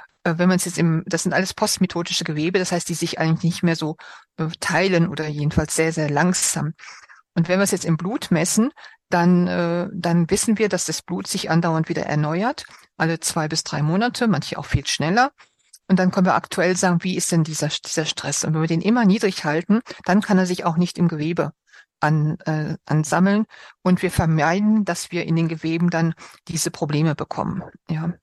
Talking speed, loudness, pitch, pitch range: 205 wpm, -21 LUFS, 170 Hz, 160-185 Hz